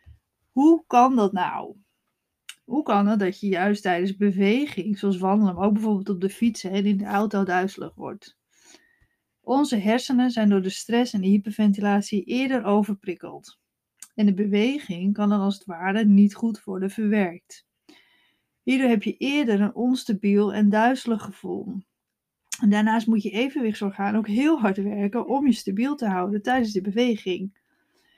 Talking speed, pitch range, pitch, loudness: 160 wpm, 200-235 Hz, 205 Hz, -23 LUFS